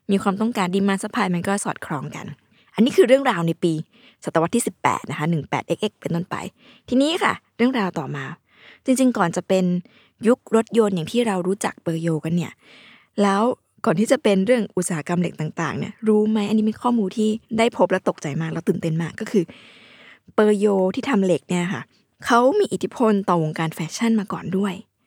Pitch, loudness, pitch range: 200 Hz, -21 LUFS, 175-225 Hz